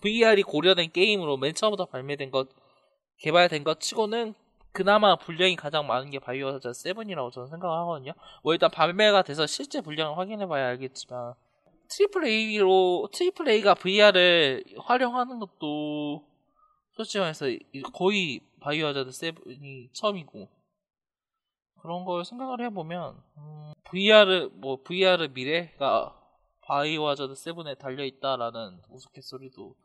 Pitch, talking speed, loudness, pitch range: 170 Hz, 315 characters per minute, -25 LUFS, 140-205 Hz